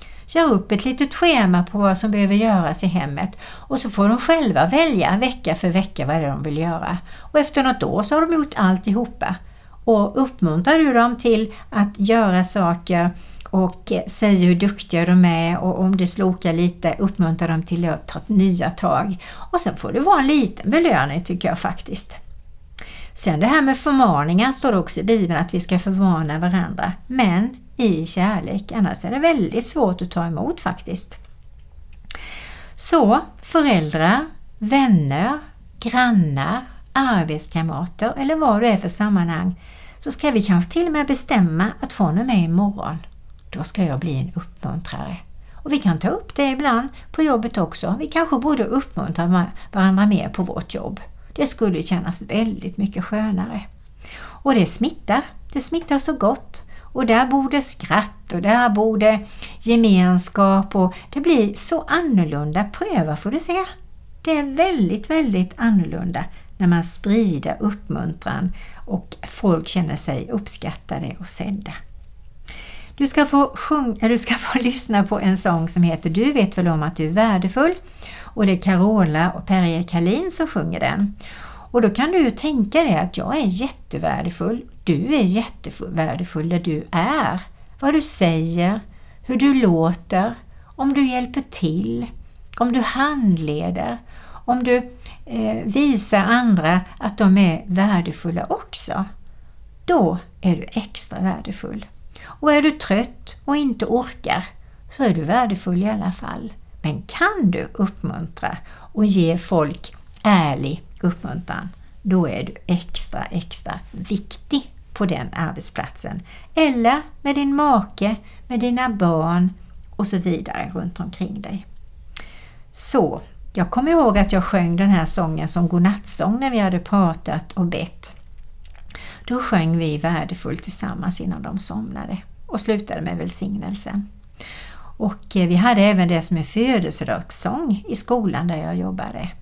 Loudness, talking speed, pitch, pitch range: -20 LUFS, 155 wpm, 195 Hz, 175-235 Hz